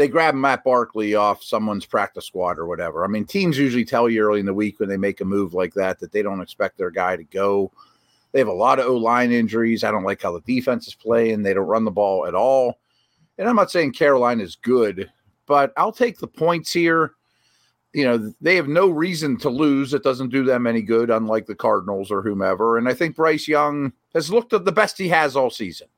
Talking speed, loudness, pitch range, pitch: 240 wpm, -20 LUFS, 105-150 Hz, 120 Hz